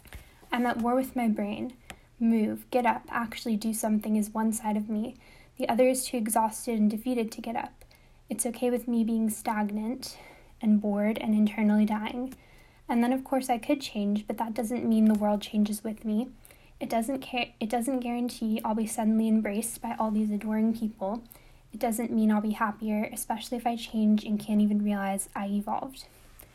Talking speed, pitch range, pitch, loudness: 190 wpm, 215-245 Hz, 225 Hz, -29 LUFS